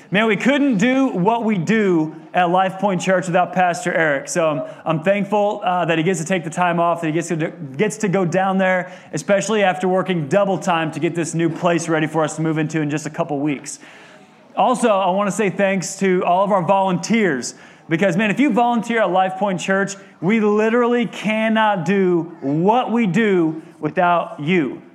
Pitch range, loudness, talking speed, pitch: 165-205 Hz, -18 LUFS, 210 wpm, 185 Hz